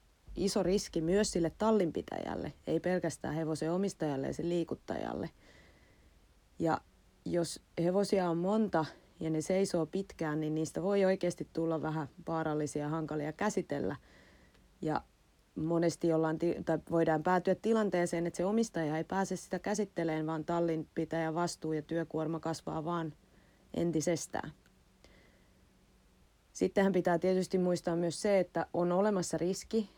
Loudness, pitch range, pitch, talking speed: -34 LUFS, 160-185 Hz, 170 Hz, 125 wpm